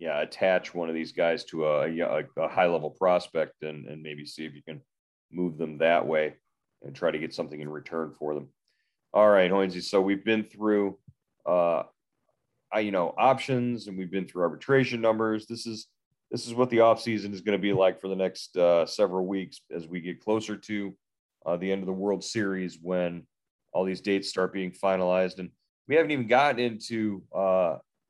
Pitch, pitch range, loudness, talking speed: 95 Hz, 85-110 Hz, -27 LUFS, 200 wpm